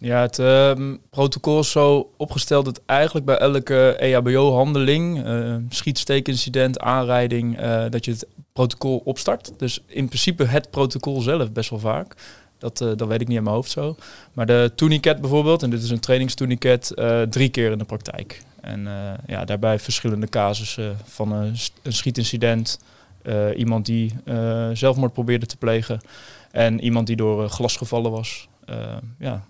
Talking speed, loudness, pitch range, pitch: 165 wpm, -21 LUFS, 115-135 Hz, 120 Hz